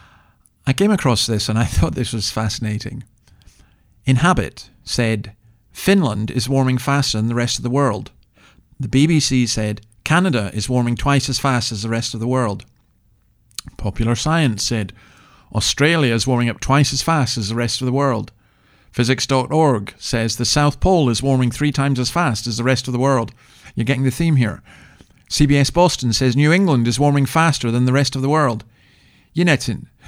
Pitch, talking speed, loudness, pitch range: 125 Hz, 180 wpm, -18 LUFS, 115-140 Hz